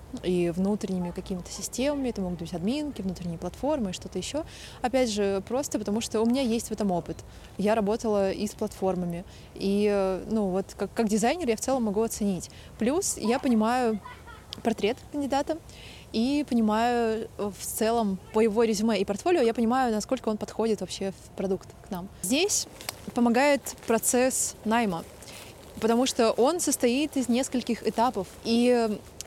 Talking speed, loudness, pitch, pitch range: 155 wpm, -27 LUFS, 220 Hz, 195-245 Hz